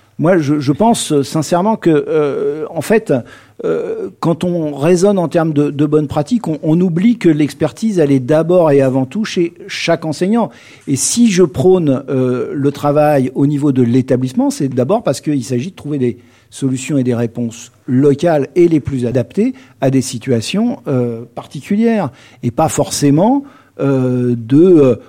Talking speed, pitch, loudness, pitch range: 170 wpm, 150 Hz, -14 LUFS, 130-175 Hz